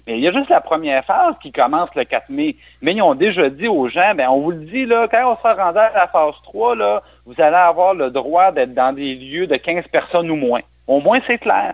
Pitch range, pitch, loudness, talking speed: 150-250 Hz, 180 Hz, -16 LUFS, 270 wpm